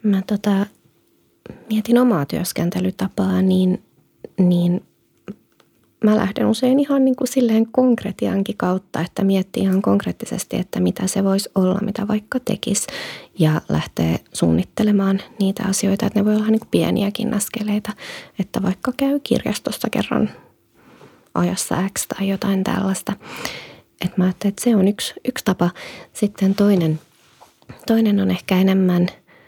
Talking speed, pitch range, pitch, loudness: 135 wpm, 185-220 Hz, 200 Hz, -20 LUFS